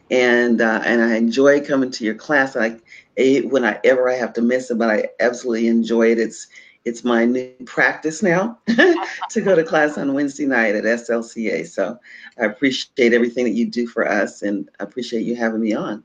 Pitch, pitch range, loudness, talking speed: 120 Hz, 115-140 Hz, -18 LUFS, 200 wpm